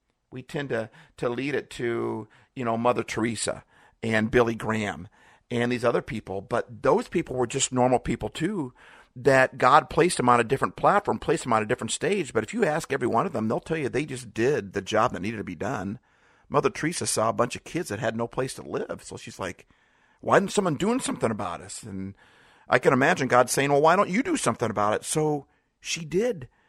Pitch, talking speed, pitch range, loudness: 120 Hz, 225 wpm, 110-140 Hz, -25 LUFS